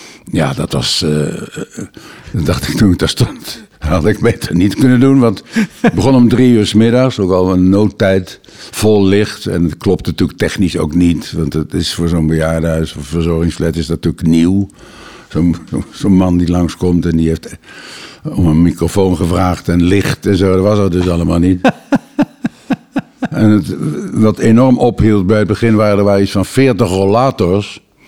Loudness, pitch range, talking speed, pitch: -12 LUFS, 85-110 Hz, 185 wpm, 95 Hz